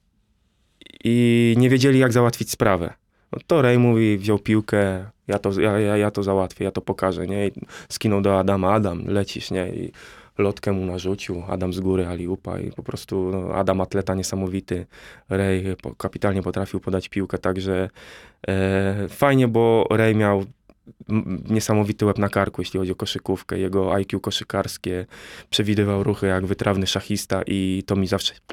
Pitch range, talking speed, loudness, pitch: 95-105 Hz, 160 wpm, -22 LUFS, 100 Hz